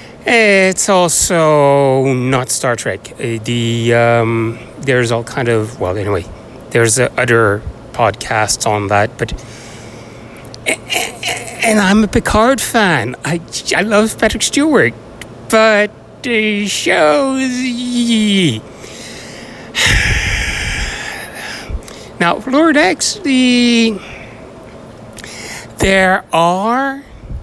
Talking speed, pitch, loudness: 85 wpm, 140 Hz, -13 LUFS